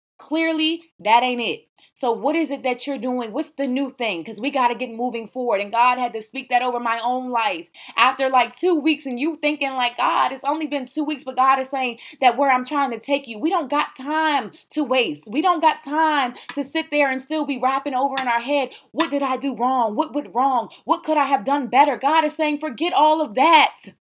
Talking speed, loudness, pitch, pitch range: 245 wpm, -21 LUFS, 275 Hz, 250-300 Hz